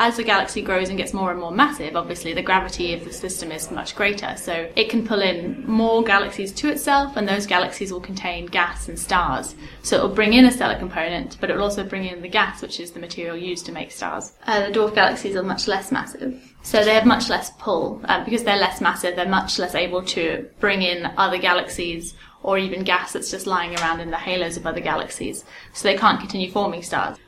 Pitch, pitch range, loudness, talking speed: 190 Hz, 180-215 Hz, -21 LUFS, 235 wpm